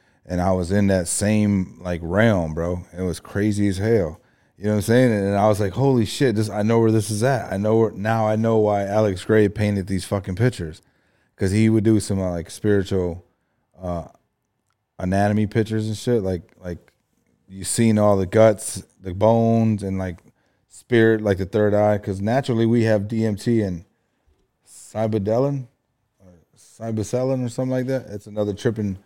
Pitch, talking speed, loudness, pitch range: 105 Hz, 185 wpm, -21 LUFS, 95-115 Hz